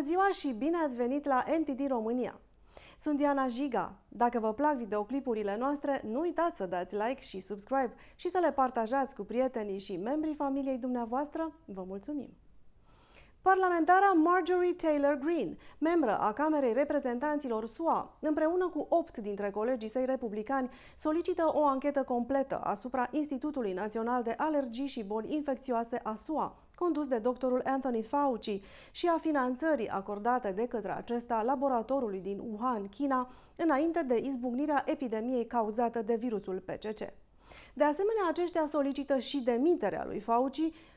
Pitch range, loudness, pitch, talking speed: 235-300 Hz, -32 LUFS, 265 Hz, 145 wpm